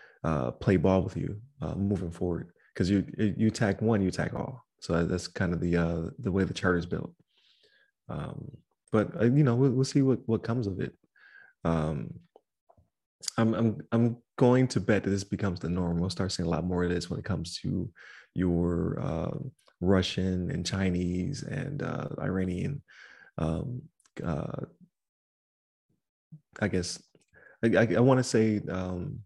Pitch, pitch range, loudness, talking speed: 95 Hz, 90-115 Hz, -29 LUFS, 170 wpm